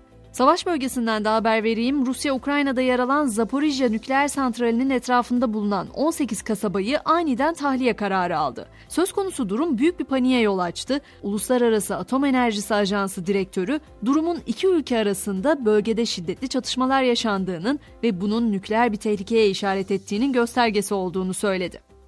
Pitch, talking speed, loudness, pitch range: 235 Hz, 135 wpm, -22 LUFS, 205-270 Hz